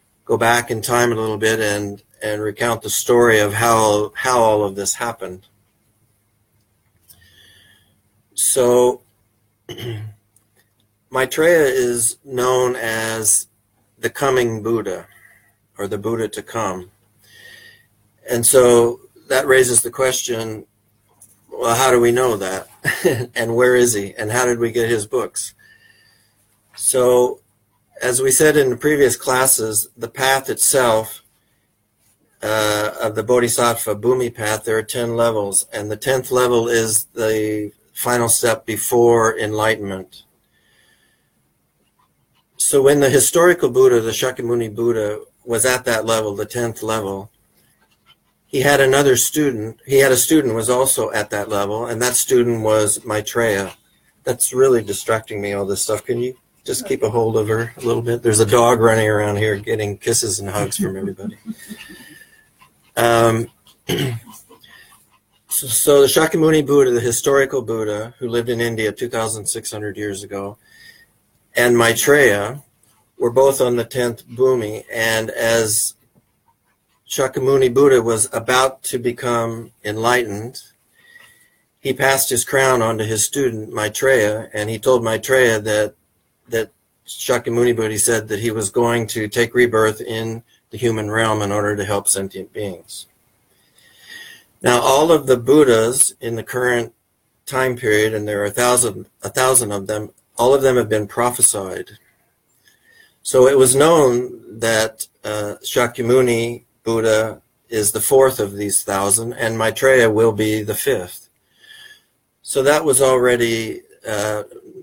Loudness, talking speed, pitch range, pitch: -17 LUFS, 140 wpm, 105-125 Hz, 115 Hz